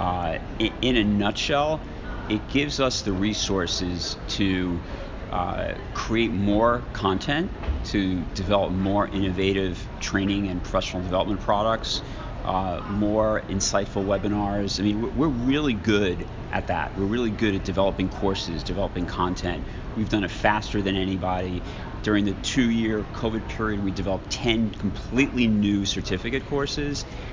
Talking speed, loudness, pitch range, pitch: 135 wpm, -25 LUFS, 95-110 Hz, 100 Hz